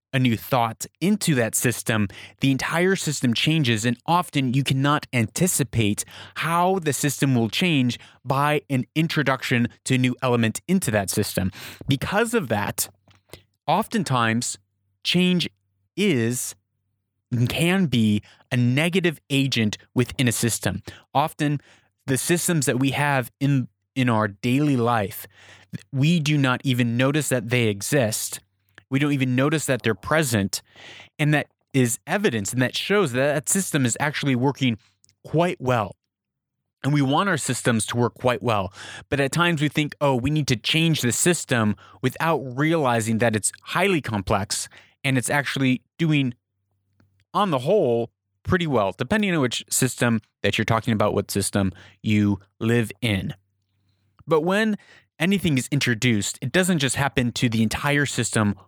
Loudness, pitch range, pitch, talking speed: -22 LUFS, 110-145 Hz, 125 Hz, 150 wpm